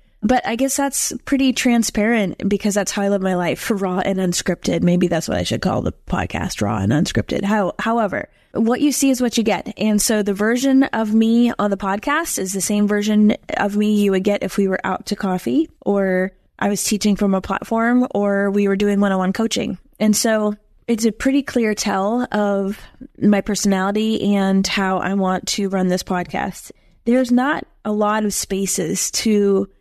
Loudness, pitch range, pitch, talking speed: -19 LUFS, 195-230 Hz, 205 Hz, 200 wpm